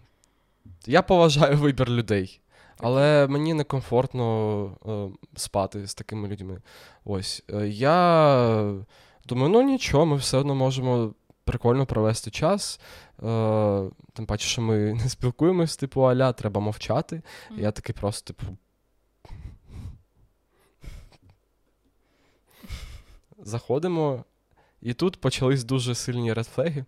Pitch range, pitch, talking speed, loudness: 105-140 Hz, 120 Hz, 105 wpm, -24 LUFS